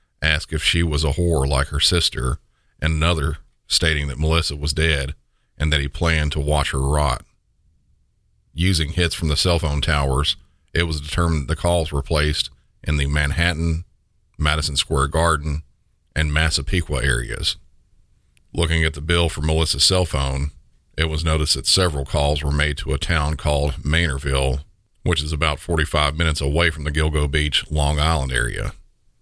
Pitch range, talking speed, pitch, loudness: 75-85 Hz, 170 wpm, 75 Hz, -20 LUFS